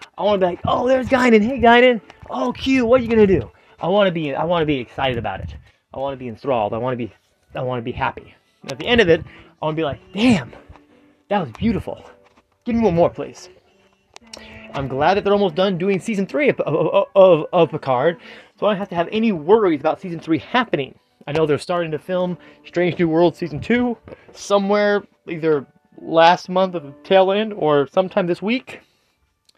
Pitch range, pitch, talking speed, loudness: 150-210 Hz, 180 Hz, 210 wpm, -18 LUFS